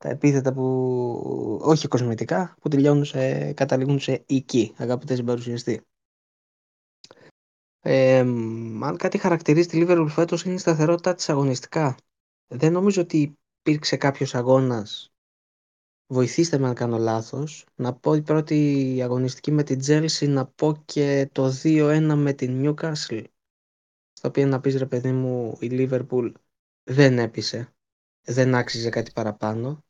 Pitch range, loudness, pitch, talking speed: 125-150 Hz, -23 LUFS, 135 Hz, 130 wpm